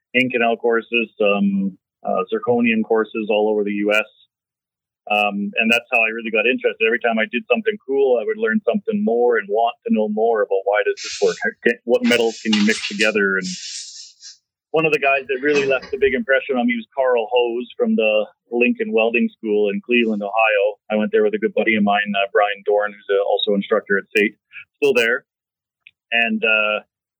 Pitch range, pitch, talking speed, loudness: 105-150 Hz, 115 Hz, 205 wpm, -18 LUFS